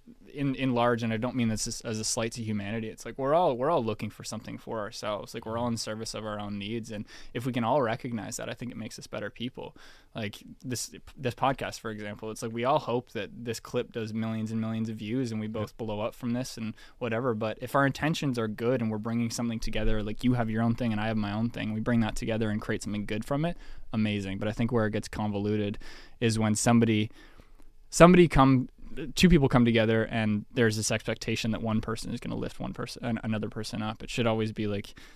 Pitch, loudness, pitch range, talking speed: 115 Hz, -29 LUFS, 110-120 Hz, 255 wpm